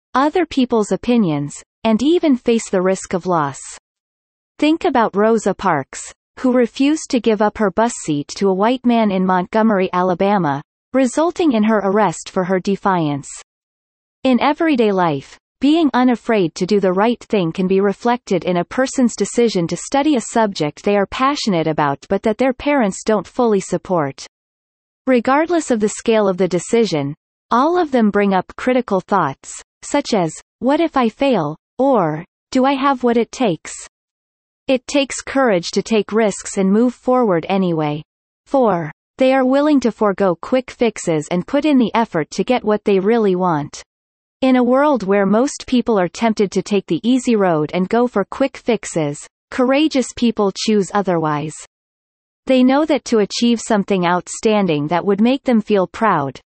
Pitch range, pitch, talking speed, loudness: 185-255 Hz, 215 Hz, 170 wpm, -17 LUFS